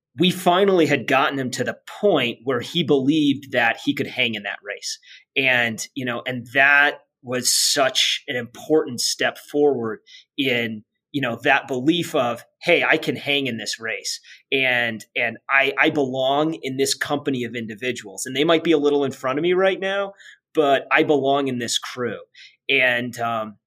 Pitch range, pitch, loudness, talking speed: 120-155 Hz, 135 Hz, -20 LUFS, 185 wpm